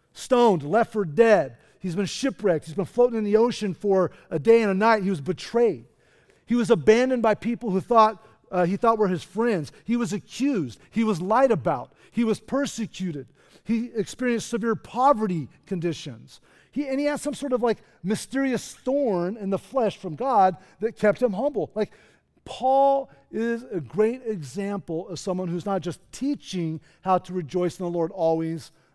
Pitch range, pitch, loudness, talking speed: 180-235 Hz, 210 Hz, -24 LUFS, 185 wpm